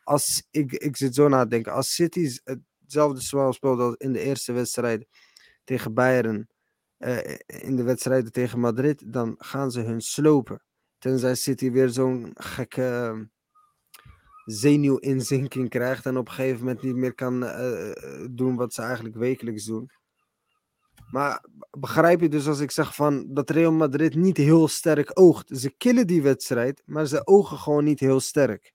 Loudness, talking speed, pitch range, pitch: -23 LUFS, 165 wpm, 125-150 Hz, 130 Hz